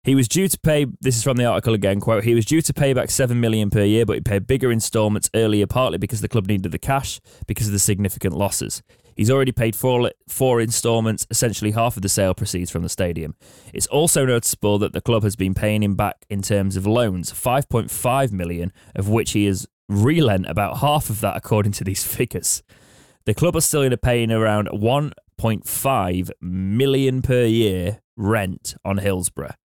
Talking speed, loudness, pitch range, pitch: 195 wpm, -20 LUFS, 100-125 Hz, 110 Hz